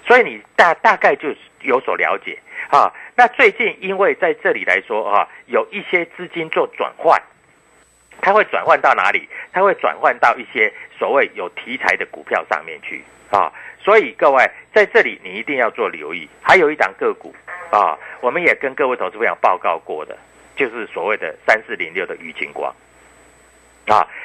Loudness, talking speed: -17 LUFS, 260 characters per minute